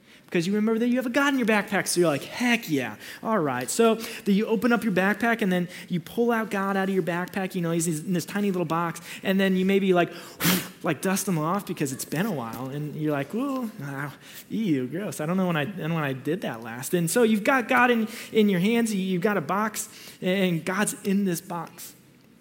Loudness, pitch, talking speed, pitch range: -25 LUFS, 190 Hz, 250 wpm, 165-220 Hz